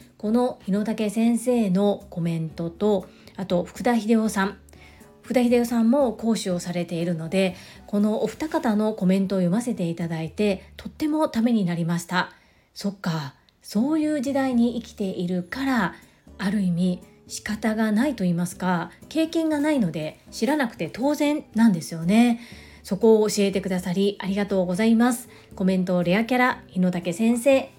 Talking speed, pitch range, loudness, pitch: 340 characters per minute, 180-235 Hz, -24 LUFS, 210 Hz